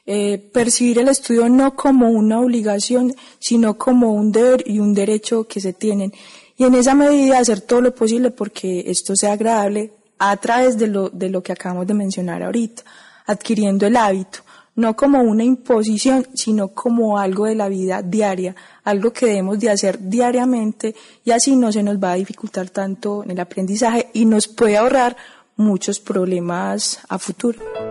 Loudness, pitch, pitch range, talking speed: -17 LUFS, 220 Hz, 200-245 Hz, 175 wpm